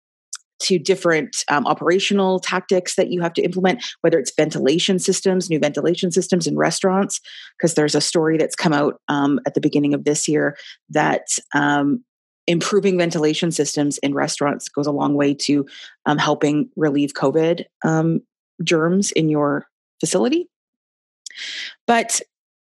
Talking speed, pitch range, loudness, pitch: 145 wpm, 150-185 Hz, -19 LUFS, 165 Hz